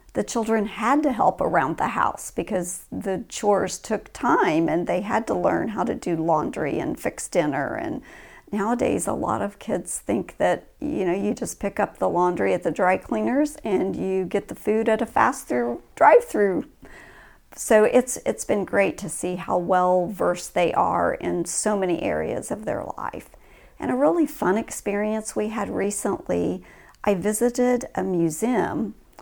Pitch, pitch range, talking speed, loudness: 205 Hz, 185-235 Hz, 180 wpm, -23 LUFS